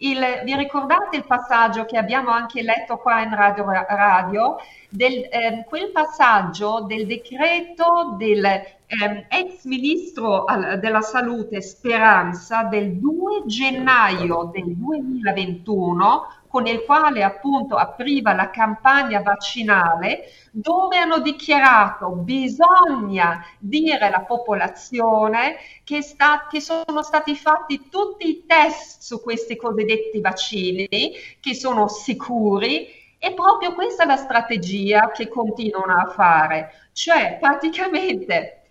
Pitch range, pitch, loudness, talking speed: 205-295 Hz, 235 Hz, -19 LUFS, 115 wpm